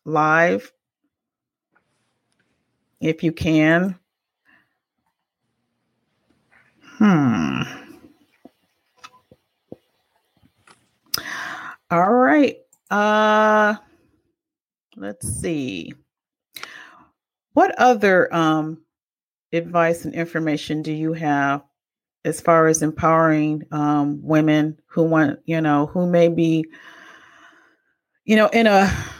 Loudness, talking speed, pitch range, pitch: -19 LUFS, 75 wpm, 155-215 Hz, 165 Hz